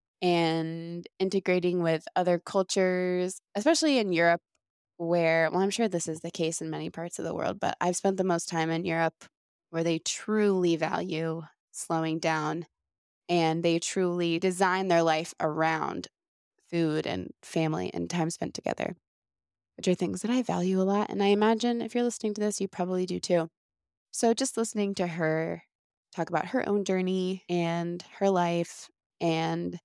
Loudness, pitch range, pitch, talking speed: -28 LUFS, 165-195 Hz, 175 Hz, 170 wpm